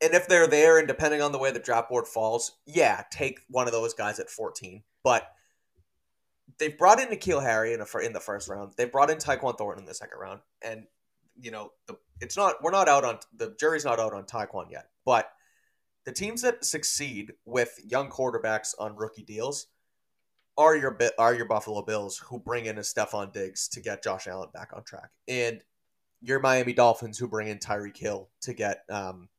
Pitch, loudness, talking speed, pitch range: 115 Hz, -27 LUFS, 205 wpm, 105-145 Hz